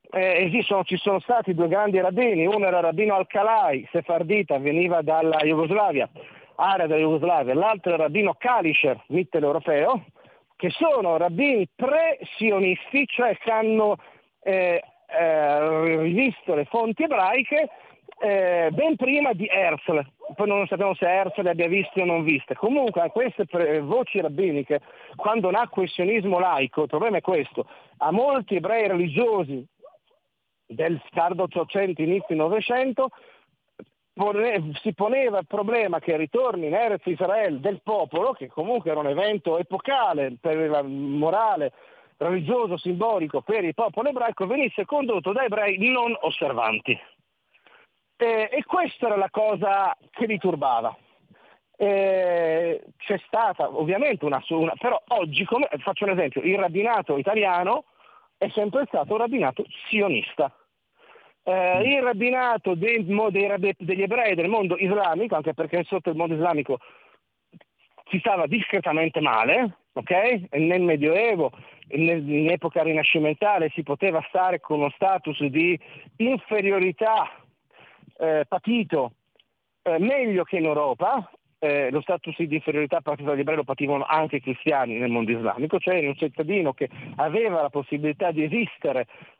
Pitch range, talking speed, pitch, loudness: 160-220 Hz, 140 wpm, 185 Hz, -23 LUFS